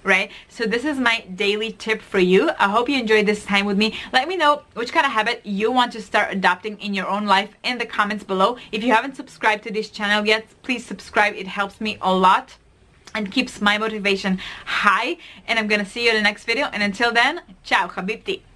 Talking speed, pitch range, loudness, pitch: 235 wpm, 200-235 Hz, -20 LUFS, 215 Hz